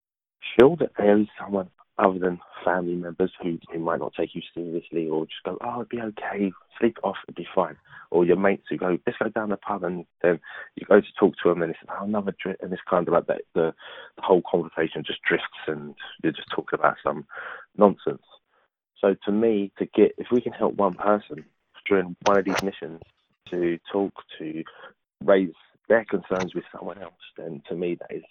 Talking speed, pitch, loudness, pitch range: 210 wpm, 95 Hz, -25 LUFS, 85-100 Hz